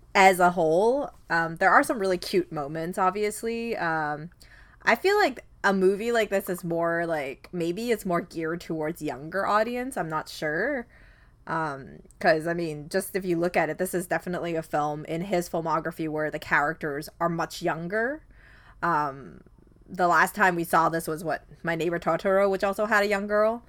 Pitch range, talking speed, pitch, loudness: 160-195 Hz, 185 wpm, 175 Hz, -26 LUFS